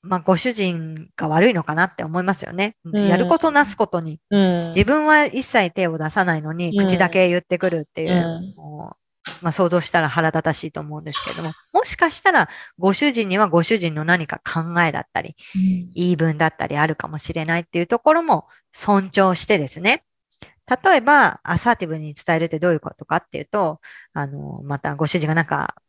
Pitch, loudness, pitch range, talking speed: 180 Hz, -19 LUFS, 160-200 Hz, 370 characters per minute